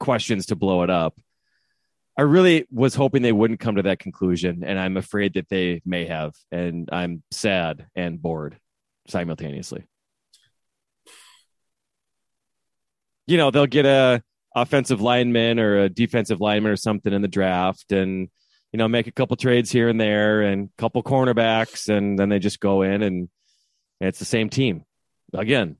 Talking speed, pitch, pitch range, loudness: 165 wpm, 105 Hz, 95-120 Hz, -21 LUFS